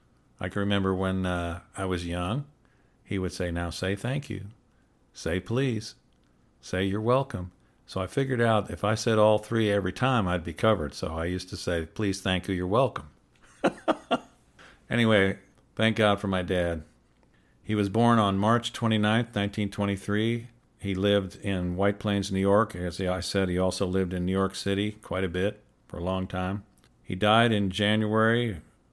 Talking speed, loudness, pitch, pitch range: 180 wpm, -27 LUFS, 100 Hz, 90-110 Hz